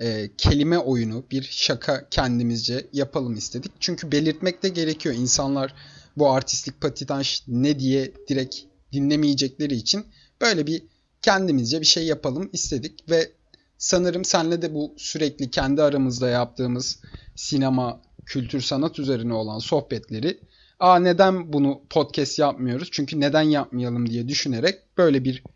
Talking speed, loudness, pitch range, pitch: 125 wpm, -23 LUFS, 125-155 Hz, 140 Hz